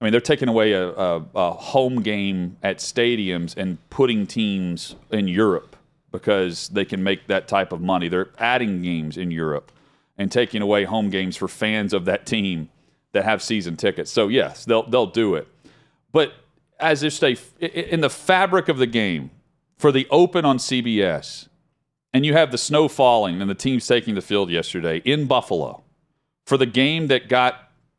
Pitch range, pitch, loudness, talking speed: 95-140 Hz, 120 Hz, -21 LUFS, 180 wpm